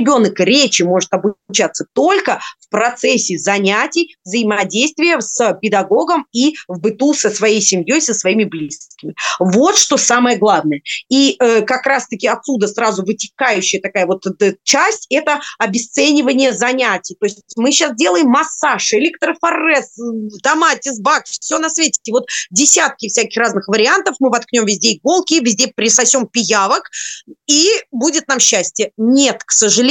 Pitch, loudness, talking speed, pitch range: 240 Hz, -13 LUFS, 140 wpm, 210-285 Hz